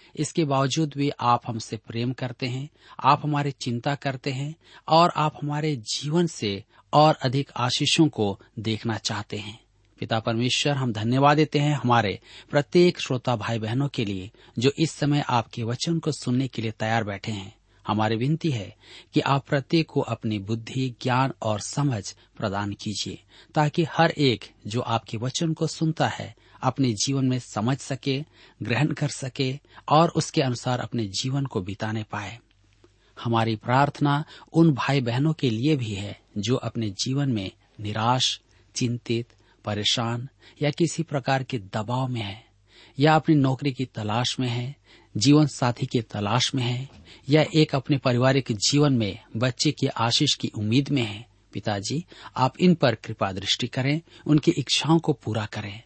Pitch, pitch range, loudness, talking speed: 125 Hz, 110-145 Hz, -25 LUFS, 160 wpm